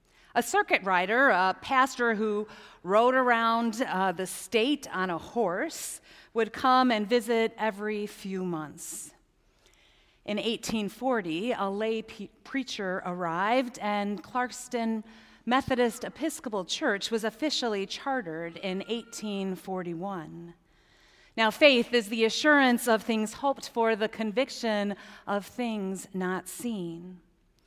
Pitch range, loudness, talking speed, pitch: 190-245 Hz, -28 LUFS, 115 wpm, 220 Hz